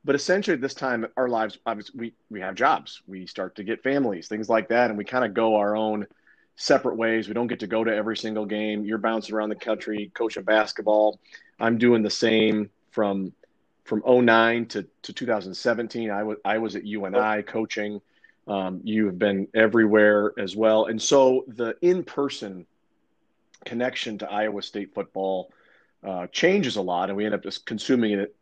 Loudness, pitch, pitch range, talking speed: -24 LUFS, 110 Hz, 105-115 Hz, 190 wpm